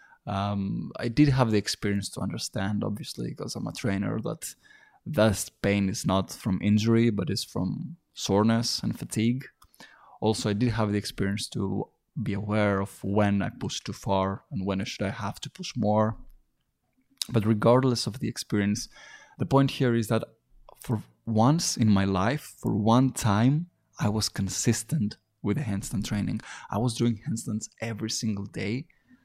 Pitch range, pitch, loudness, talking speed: 100-125 Hz, 110 Hz, -27 LUFS, 170 wpm